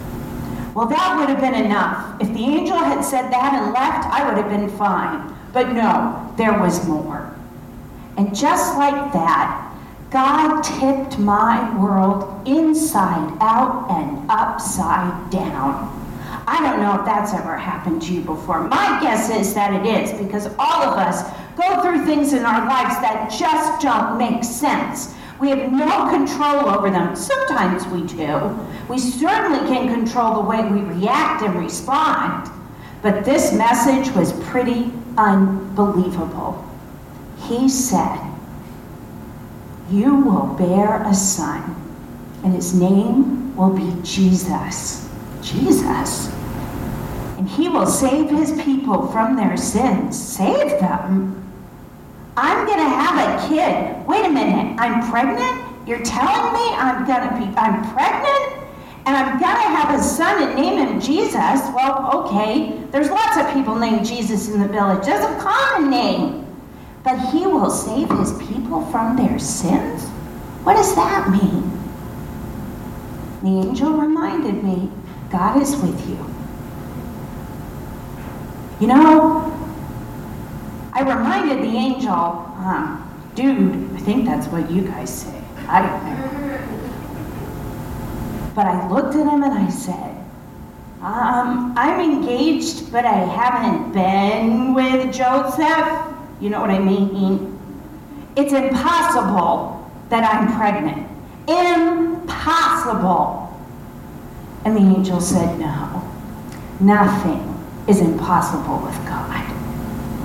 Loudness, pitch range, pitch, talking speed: -18 LUFS, 200-280 Hz, 245 Hz, 130 wpm